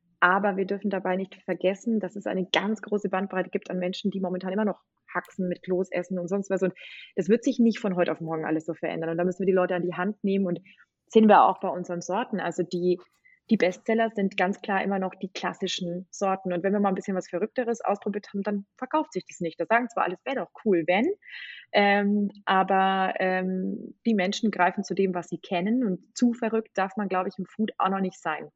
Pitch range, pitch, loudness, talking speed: 180-210 Hz, 190 Hz, -27 LUFS, 240 wpm